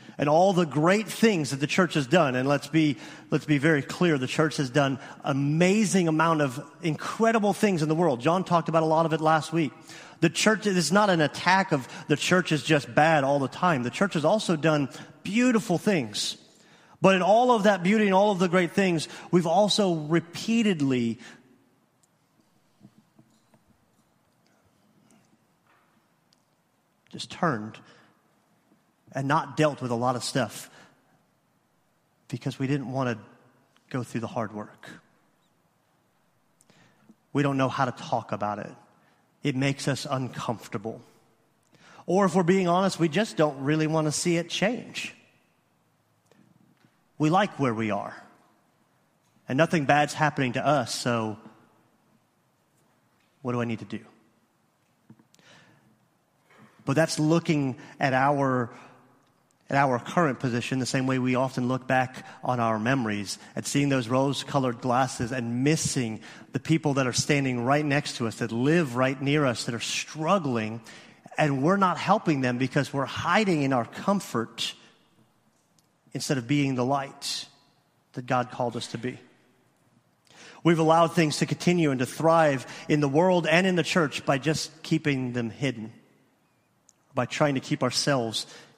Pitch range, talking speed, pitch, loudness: 125-165 Hz, 155 wpm, 145 Hz, -25 LUFS